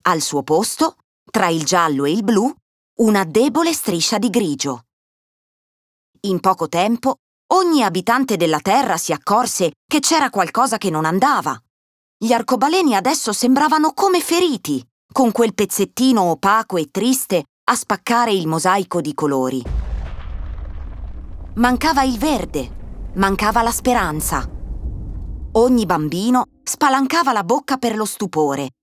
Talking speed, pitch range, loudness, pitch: 125 wpm, 155-255 Hz, -17 LUFS, 200 Hz